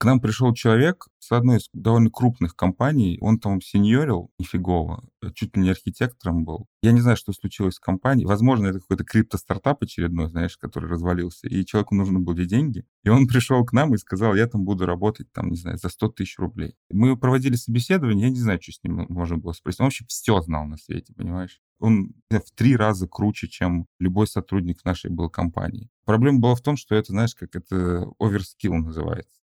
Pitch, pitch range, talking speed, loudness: 105 Hz, 90-120 Hz, 205 wpm, -22 LUFS